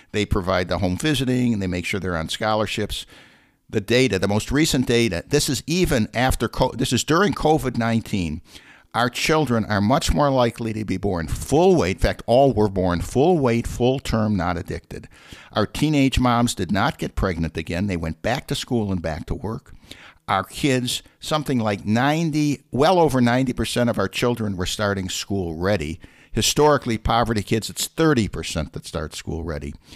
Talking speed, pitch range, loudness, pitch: 185 wpm, 95-130 Hz, -21 LUFS, 115 Hz